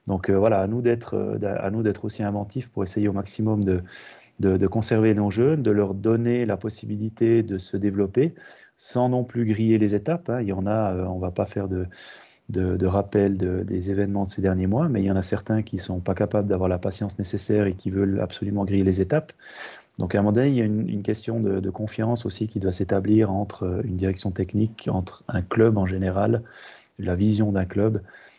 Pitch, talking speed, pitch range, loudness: 100 Hz, 230 wpm, 95-110 Hz, -24 LUFS